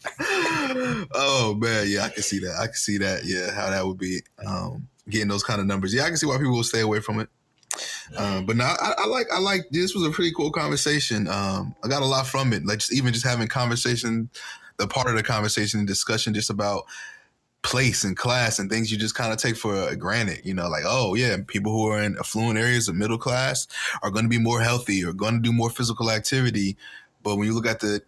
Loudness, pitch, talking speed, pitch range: -24 LUFS, 115 Hz, 245 wpm, 105-125 Hz